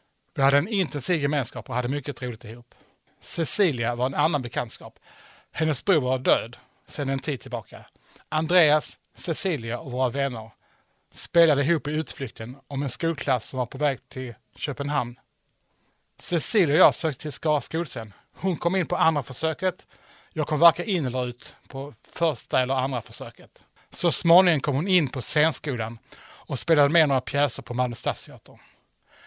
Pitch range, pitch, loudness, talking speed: 125-160 Hz, 140 Hz, -24 LUFS, 160 wpm